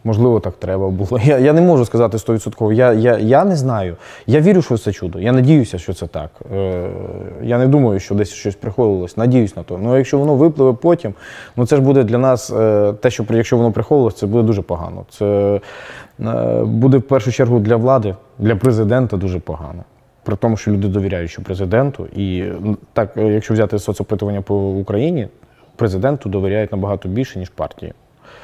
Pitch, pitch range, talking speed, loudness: 110 Hz, 100-125 Hz, 190 wpm, -16 LUFS